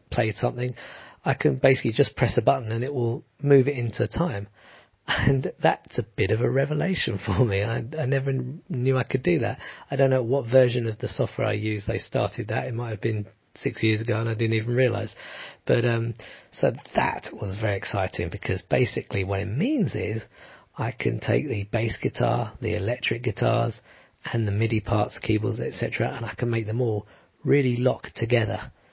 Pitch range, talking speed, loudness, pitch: 110-130 Hz, 200 wpm, -25 LUFS, 115 Hz